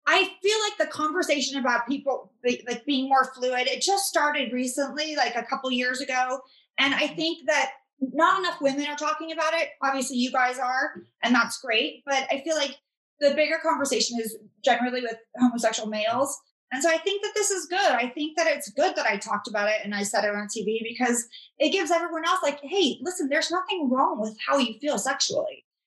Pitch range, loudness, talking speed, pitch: 245-315 Hz, -25 LUFS, 215 wpm, 275 Hz